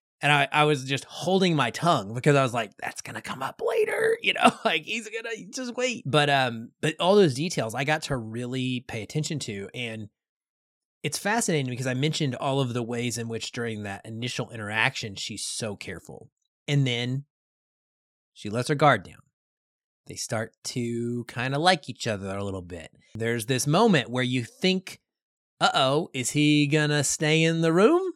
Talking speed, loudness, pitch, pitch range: 190 wpm, -25 LUFS, 140 Hz, 120-165 Hz